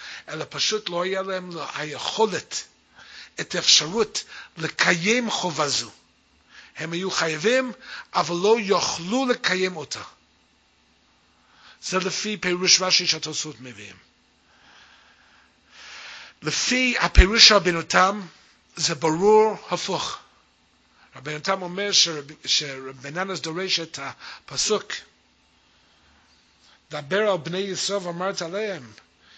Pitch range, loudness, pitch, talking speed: 120-190 Hz, -22 LUFS, 170 Hz, 90 wpm